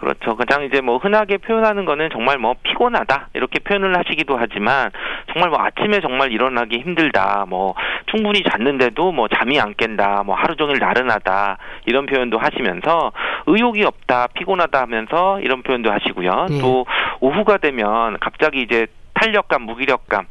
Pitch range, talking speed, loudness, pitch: 115-175 Hz, 365 characters per minute, -17 LUFS, 130 Hz